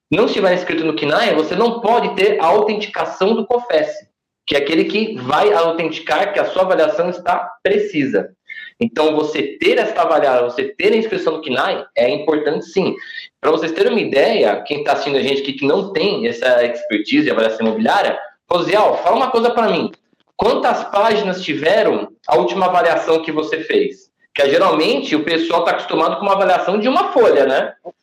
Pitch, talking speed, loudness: 190 Hz, 185 wpm, -16 LUFS